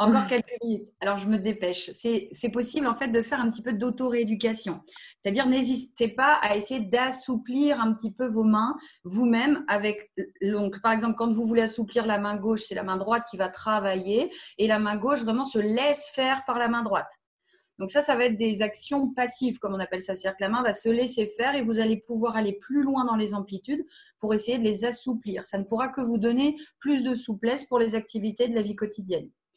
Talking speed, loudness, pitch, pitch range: 225 wpm, -26 LUFS, 230 Hz, 210-250 Hz